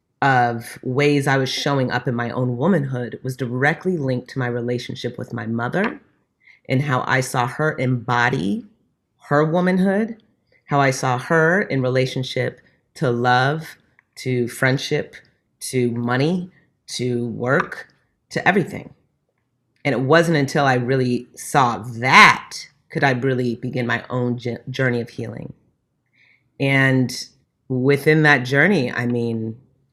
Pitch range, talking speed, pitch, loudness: 120-145 Hz, 130 wpm, 130 Hz, -19 LUFS